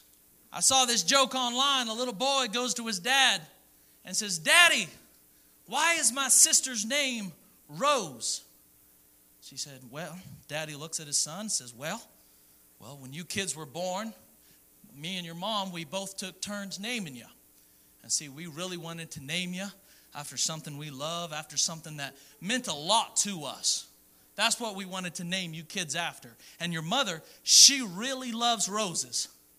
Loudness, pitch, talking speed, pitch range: -27 LUFS, 175 Hz, 170 wpm, 140-225 Hz